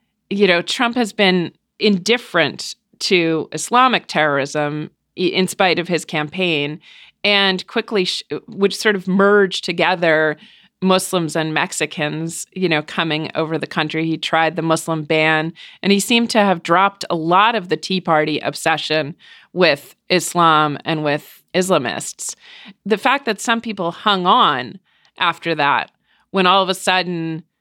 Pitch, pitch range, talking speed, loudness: 175 Hz, 160-200 Hz, 150 wpm, -17 LUFS